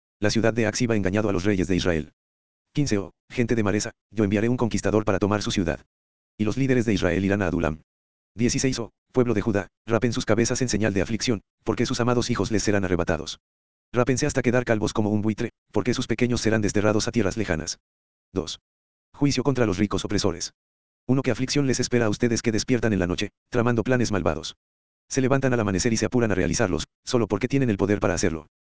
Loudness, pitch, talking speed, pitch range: -24 LUFS, 105 Hz, 215 wpm, 90-120 Hz